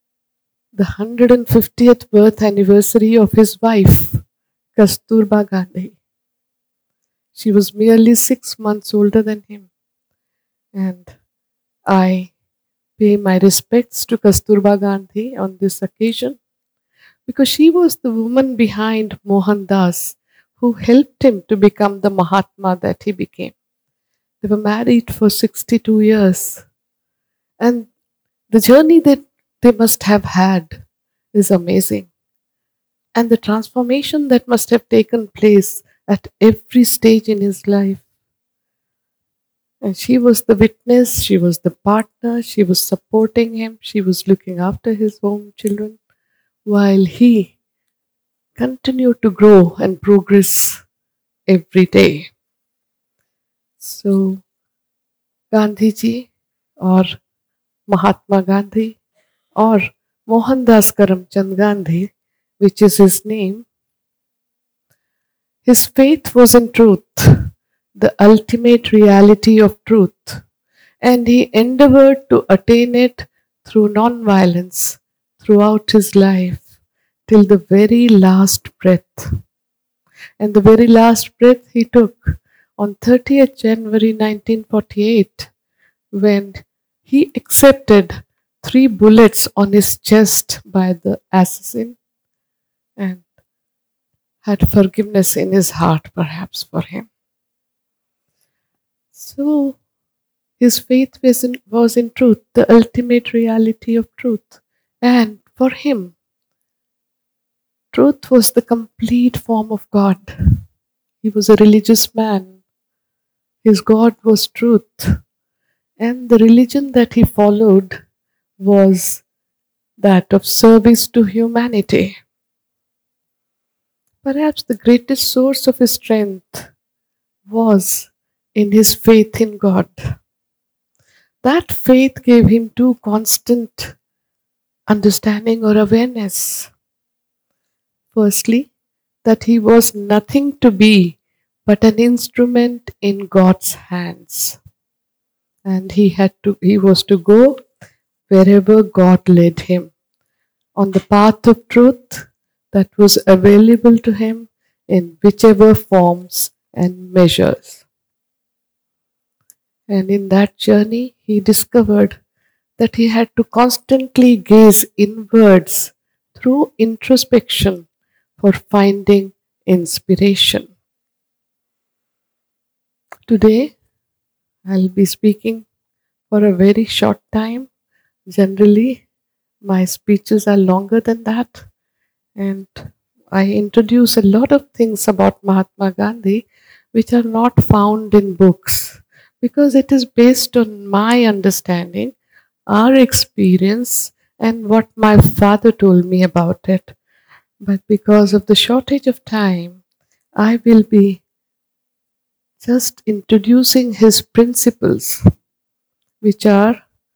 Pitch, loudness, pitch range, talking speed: 215 Hz, -12 LUFS, 195-235 Hz, 105 wpm